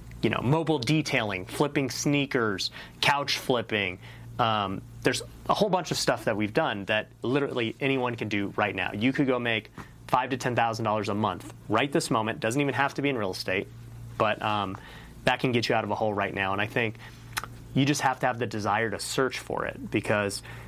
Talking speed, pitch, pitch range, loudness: 215 wpm, 120 Hz, 105-135 Hz, -27 LUFS